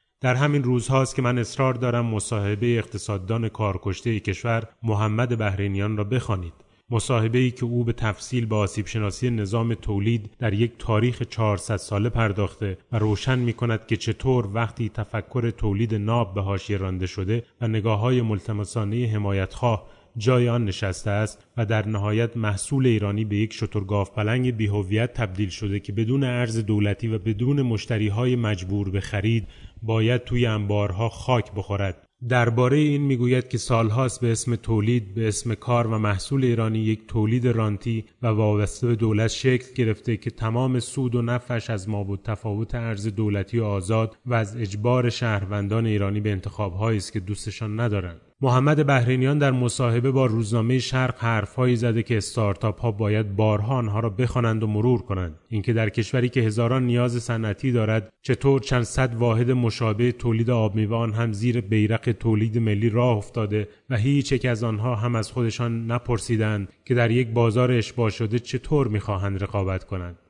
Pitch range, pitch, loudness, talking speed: 105-120 Hz, 115 Hz, -24 LUFS, 165 wpm